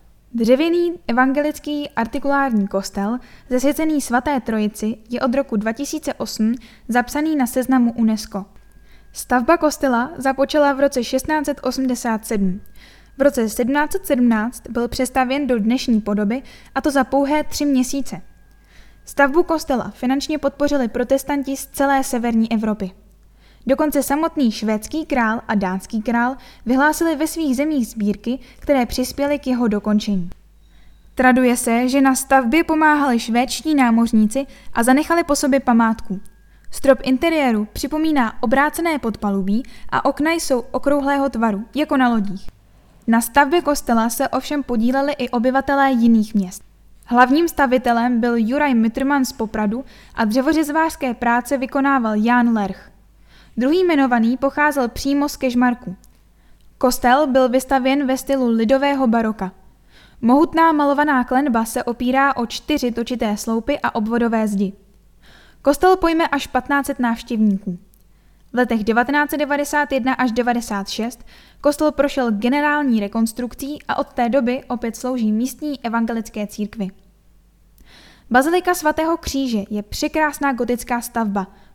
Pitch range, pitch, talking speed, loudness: 230-280 Hz, 255 Hz, 120 wpm, -19 LUFS